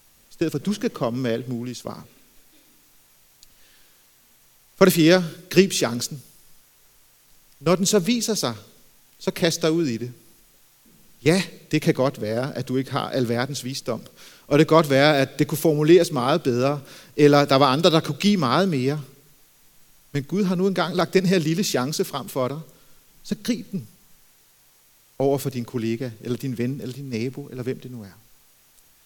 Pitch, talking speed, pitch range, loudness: 145 Hz, 180 wpm, 130-170 Hz, -22 LUFS